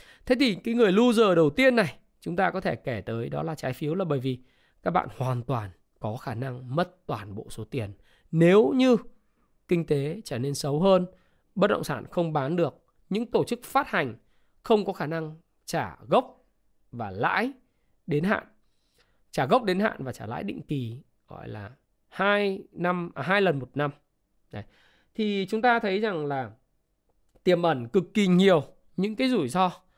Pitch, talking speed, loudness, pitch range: 165 Hz, 190 wpm, -26 LUFS, 130-200 Hz